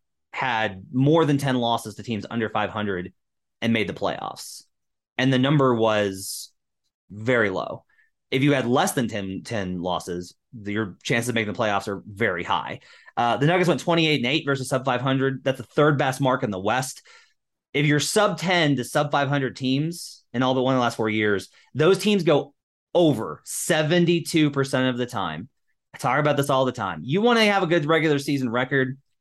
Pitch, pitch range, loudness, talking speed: 130 Hz, 110-145 Hz, -23 LUFS, 205 wpm